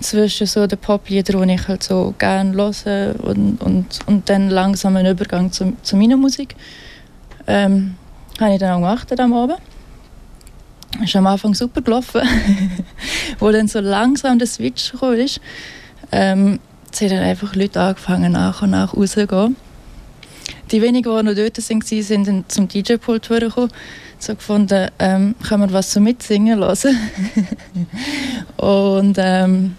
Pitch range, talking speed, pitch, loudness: 190-225 Hz, 155 wpm, 205 Hz, -16 LUFS